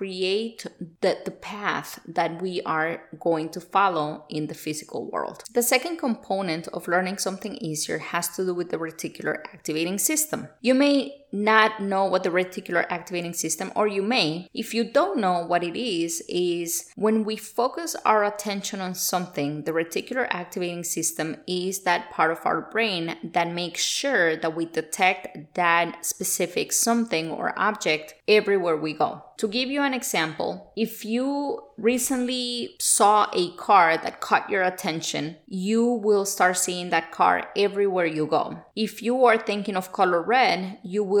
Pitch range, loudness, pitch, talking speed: 170-220 Hz, -24 LUFS, 185 Hz, 165 wpm